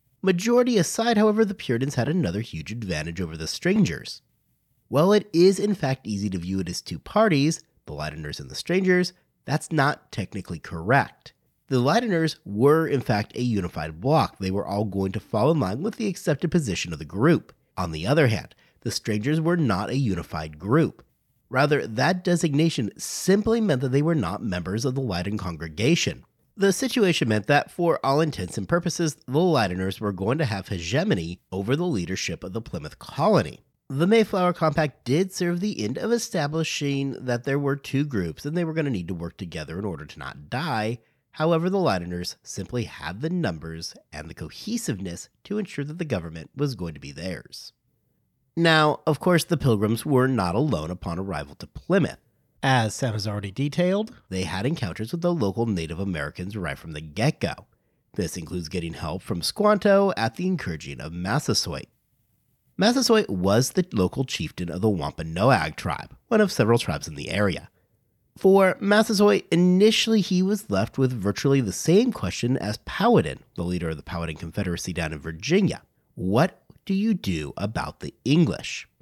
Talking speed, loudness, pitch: 180 wpm, -24 LUFS, 130 Hz